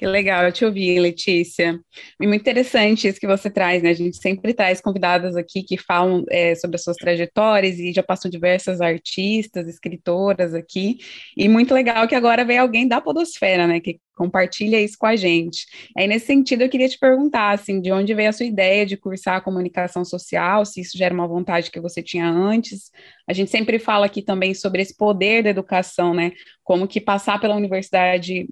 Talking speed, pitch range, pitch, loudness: 200 wpm, 180-215 Hz, 190 Hz, -19 LUFS